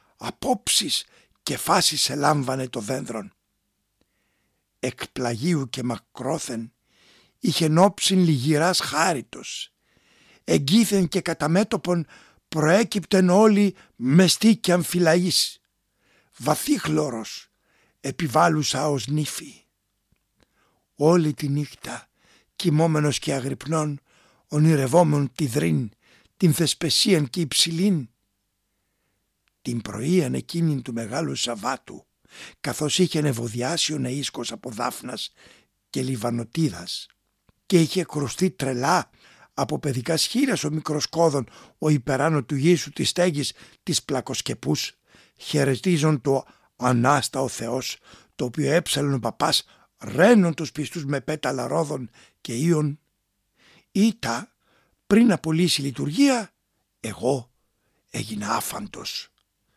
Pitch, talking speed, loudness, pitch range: 150 Hz, 100 wpm, -23 LUFS, 130-170 Hz